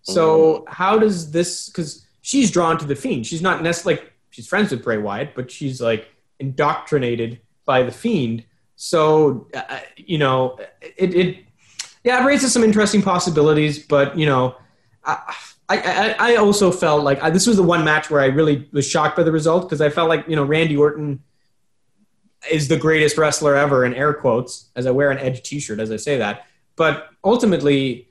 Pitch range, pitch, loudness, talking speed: 135-175 Hz, 155 Hz, -18 LUFS, 190 wpm